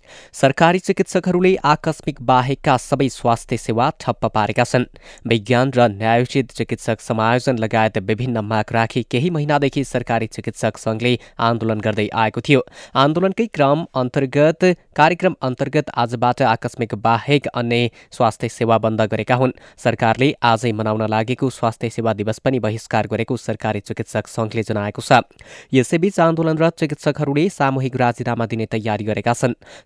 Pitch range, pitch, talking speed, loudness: 115-140 Hz, 120 Hz, 135 wpm, -19 LUFS